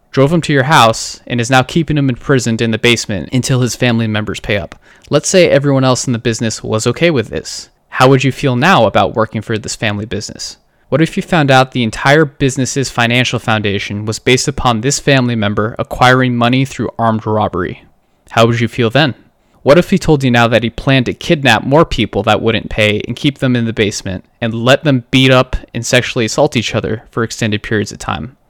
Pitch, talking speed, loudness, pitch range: 120 Hz, 220 wpm, -13 LUFS, 110-135 Hz